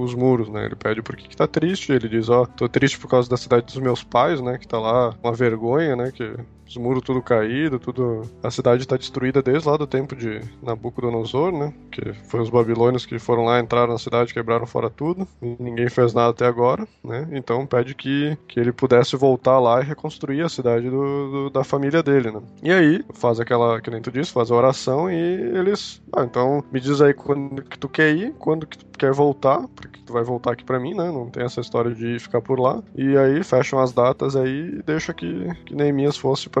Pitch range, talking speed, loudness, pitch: 120-140 Hz, 230 wpm, -21 LUFS, 125 Hz